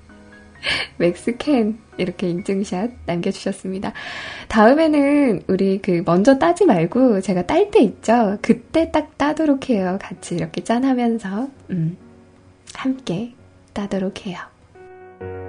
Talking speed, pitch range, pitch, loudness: 230 characters per minute, 185-275 Hz, 220 Hz, -19 LUFS